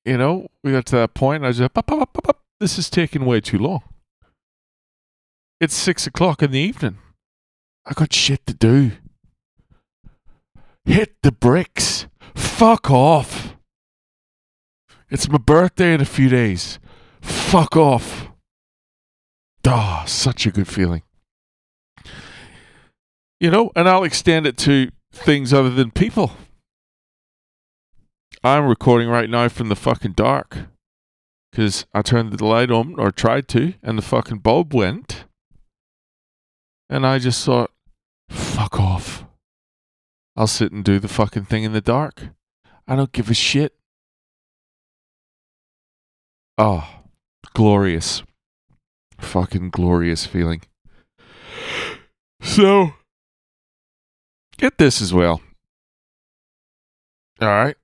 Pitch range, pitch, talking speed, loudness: 95-145 Hz, 120 Hz, 120 wpm, -18 LUFS